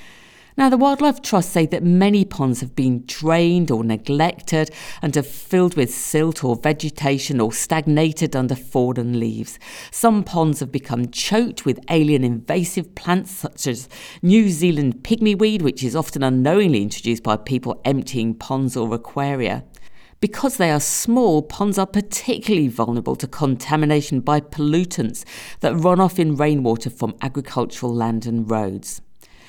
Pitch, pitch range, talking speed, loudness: 150 Hz, 125-175 Hz, 150 wpm, -19 LUFS